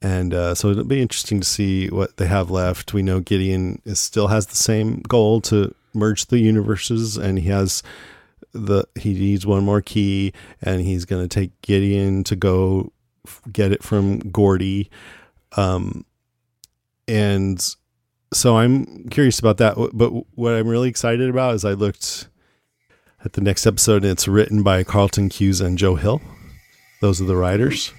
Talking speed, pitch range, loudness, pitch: 170 wpm, 95-115 Hz, -19 LUFS, 100 Hz